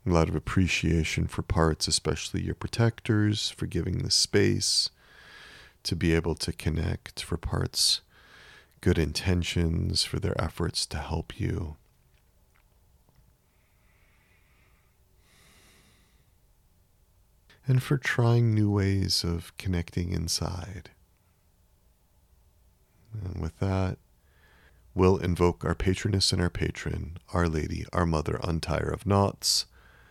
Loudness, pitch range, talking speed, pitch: -27 LUFS, 80-95 Hz, 105 wpm, 90 Hz